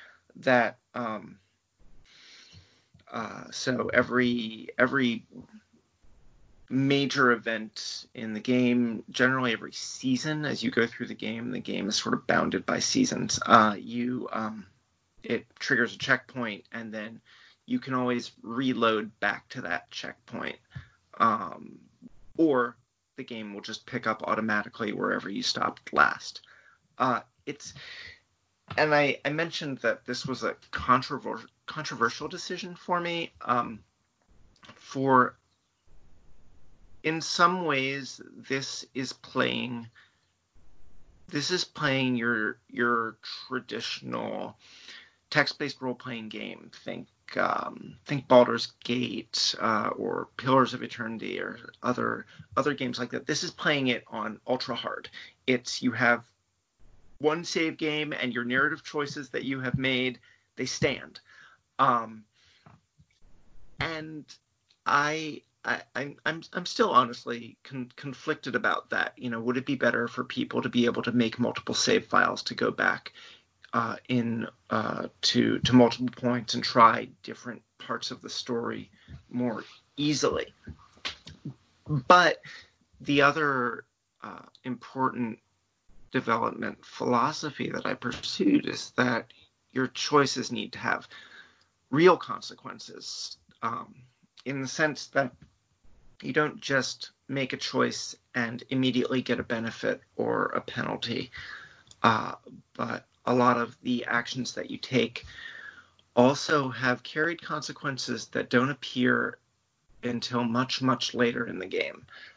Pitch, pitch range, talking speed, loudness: 125 Hz, 115-140 Hz, 130 wpm, -28 LUFS